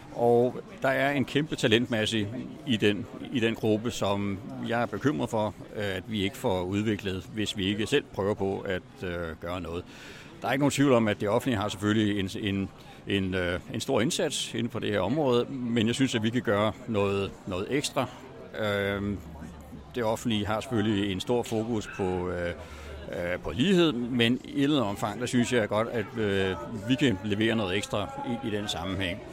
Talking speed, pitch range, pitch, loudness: 200 wpm, 100-120 Hz, 105 Hz, -28 LUFS